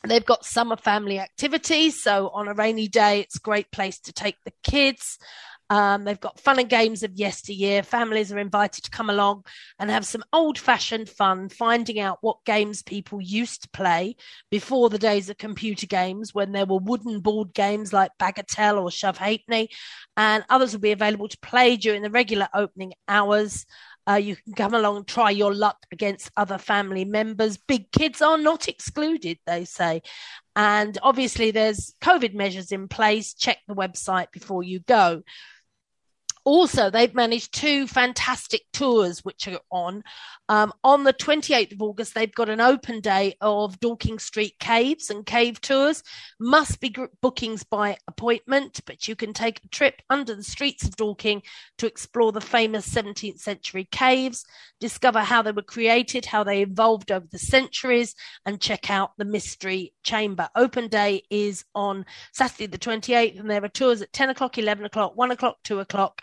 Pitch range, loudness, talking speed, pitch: 200-240 Hz, -23 LUFS, 175 wpm, 215 Hz